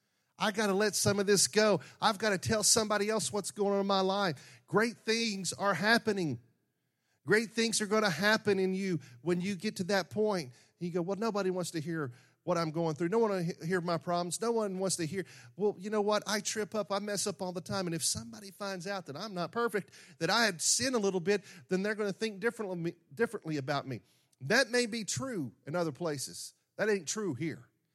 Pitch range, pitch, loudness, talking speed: 165-210 Hz, 195 Hz, -32 LUFS, 235 wpm